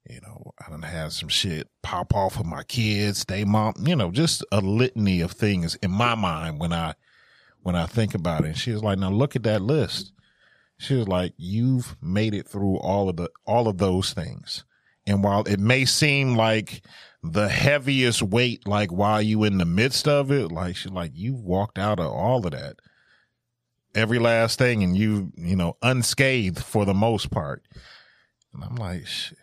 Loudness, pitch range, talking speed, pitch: -23 LUFS, 95-120 Hz, 195 wpm, 105 Hz